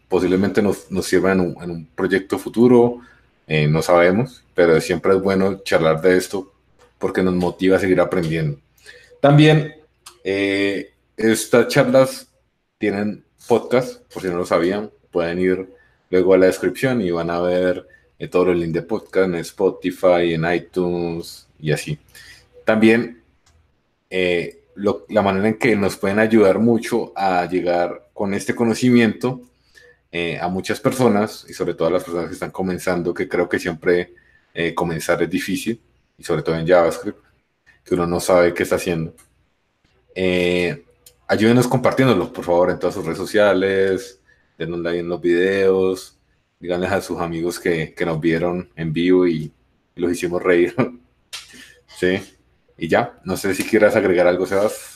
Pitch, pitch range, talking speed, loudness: 90 Hz, 85-110 Hz, 160 wpm, -19 LUFS